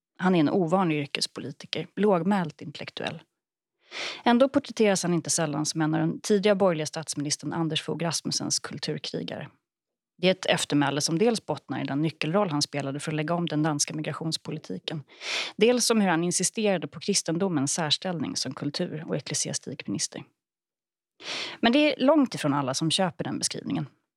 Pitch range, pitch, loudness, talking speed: 150-195 Hz, 165 Hz, -26 LUFS, 160 wpm